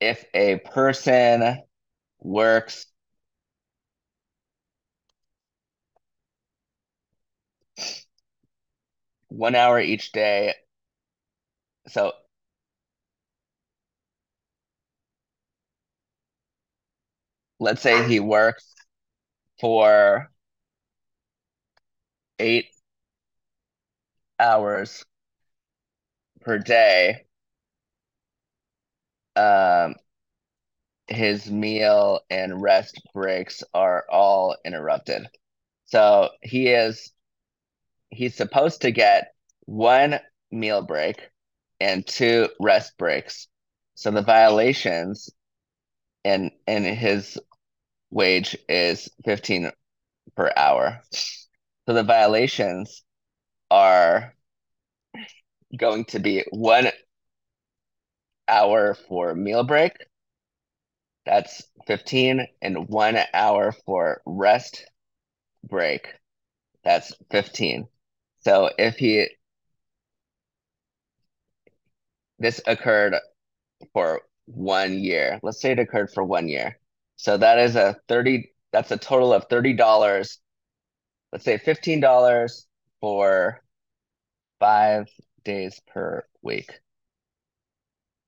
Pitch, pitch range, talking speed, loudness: 110 Hz, 100-125 Hz, 75 wpm, -21 LUFS